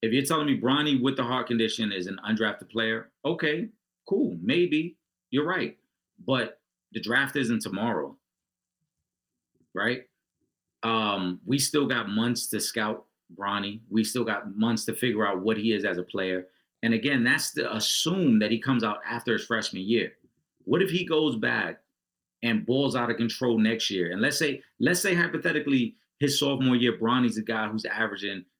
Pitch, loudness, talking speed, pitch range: 115 Hz, -27 LUFS, 175 wpm, 110-135 Hz